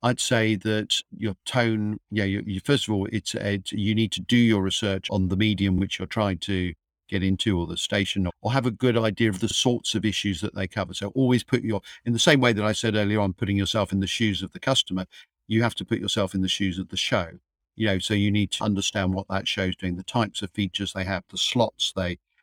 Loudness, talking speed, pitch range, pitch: -25 LUFS, 260 wpm, 95-110 Hz, 100 Hz